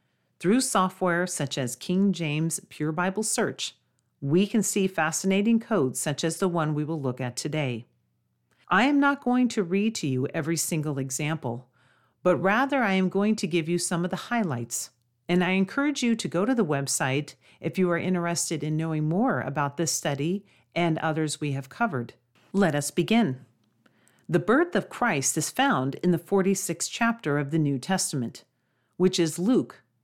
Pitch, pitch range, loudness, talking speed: 170 Hz, 145-195 Hz, -26 LUFS, 180 wpm